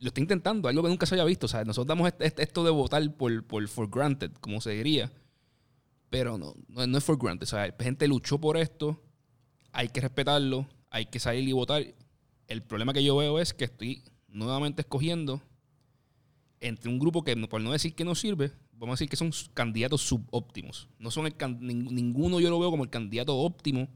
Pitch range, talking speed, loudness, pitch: 120-150 Hz, 215 wpm, -30 LUFS, 135 Hz